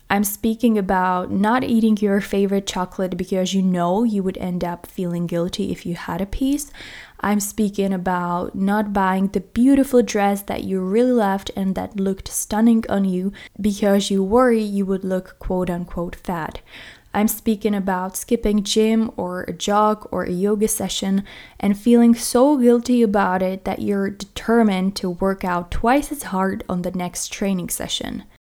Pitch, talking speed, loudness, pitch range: 200 Hz, 170 wpm, -20 LUFS, 185-220 Hz